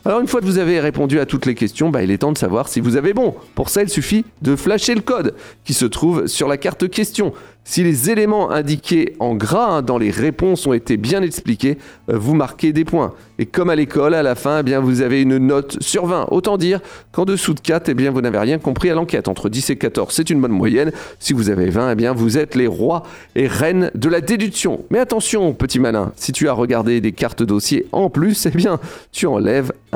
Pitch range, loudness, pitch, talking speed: 130-185 Hz, -17 LUFS, 150 Hz, 250 wpm